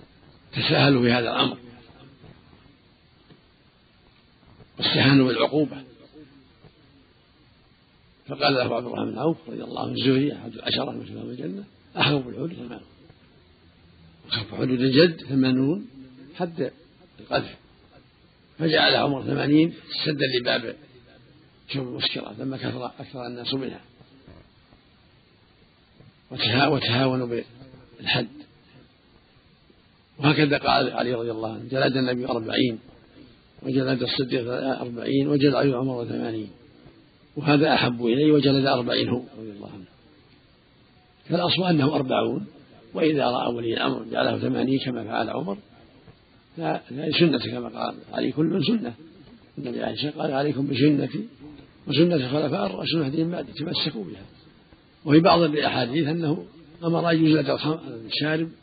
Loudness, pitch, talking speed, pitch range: -23 LUFS, 135 Hz, 110 wpm, 120-150 Hz